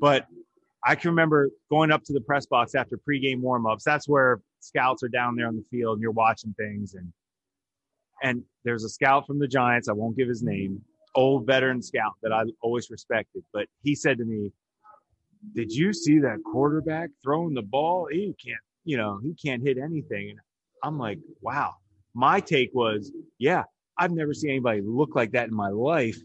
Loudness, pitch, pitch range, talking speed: -26 LUFS, 130 Hz, 110-150 Hz, 195 wpm